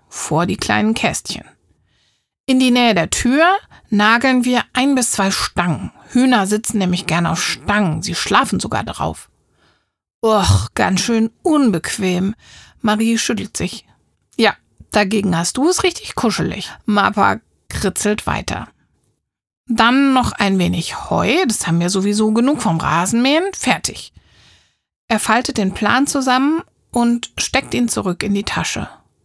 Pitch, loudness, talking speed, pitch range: 220 Hz, -16 LUFS, 135 wpm, 195-255 Hz